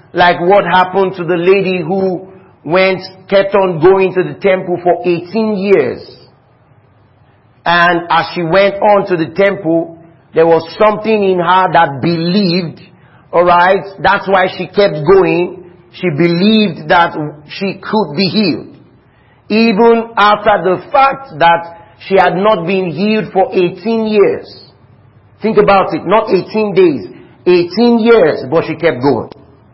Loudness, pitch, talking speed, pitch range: -11 LUFS, 185 Hz, 140 wpm, 170-200 Hz